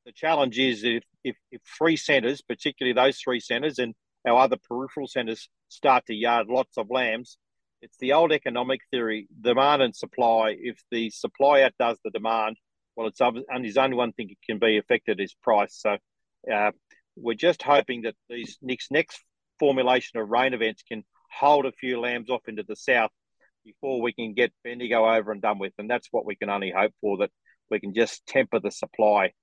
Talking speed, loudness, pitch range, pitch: 195 wpm, -25 LUFS, 110-130 Hz, 120 Hz